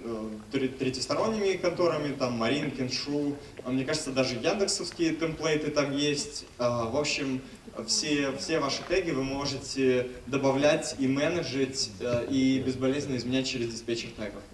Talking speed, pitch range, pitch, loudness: 120 wpm, 125-150 Hz, 135 Hz, -29 LUFS